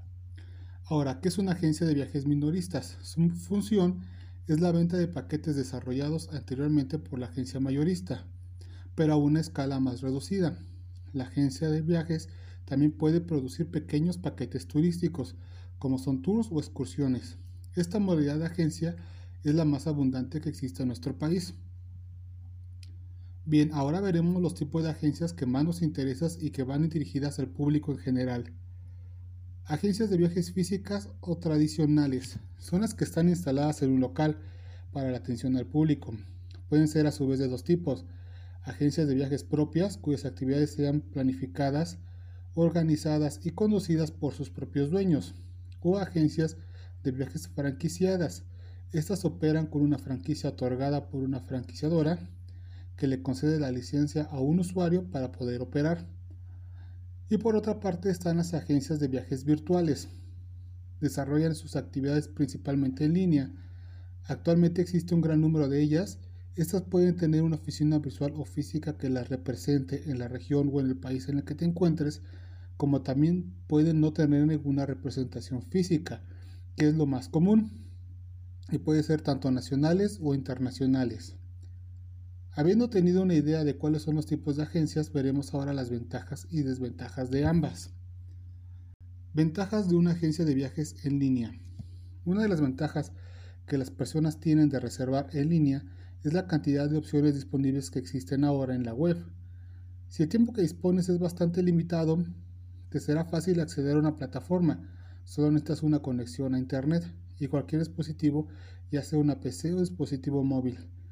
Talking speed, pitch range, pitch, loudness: 155 wpm, 100-155 Hz, 140 Hz, -29 LUFS